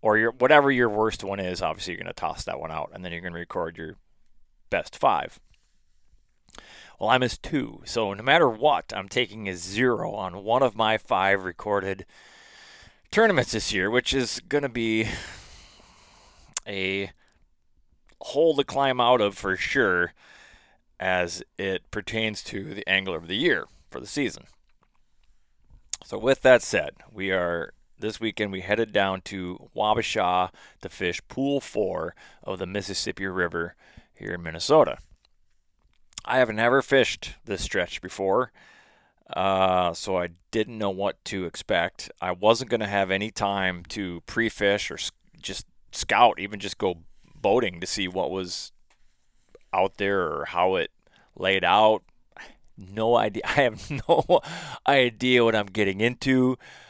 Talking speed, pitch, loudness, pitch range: 155 wpm, 100 Hz, -25 LUFS, 90-115 Hz